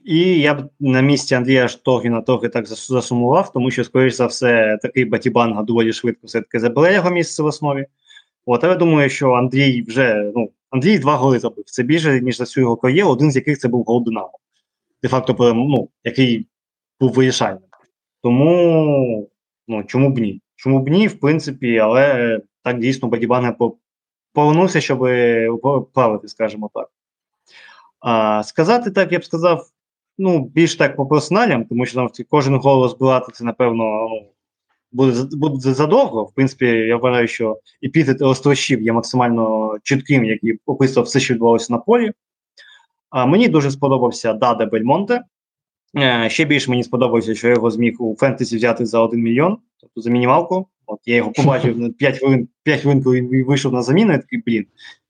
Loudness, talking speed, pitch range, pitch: -16 LUFS, 165 wpm, 120-145 Hz, 125 Hz